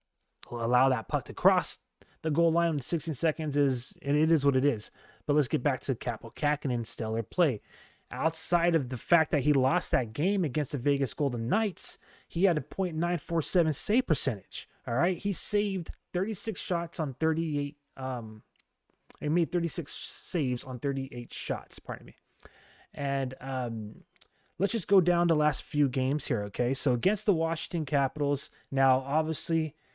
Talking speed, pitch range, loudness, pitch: 170 wpm, 130-170 Hz, -29 LUFS, 150 Hz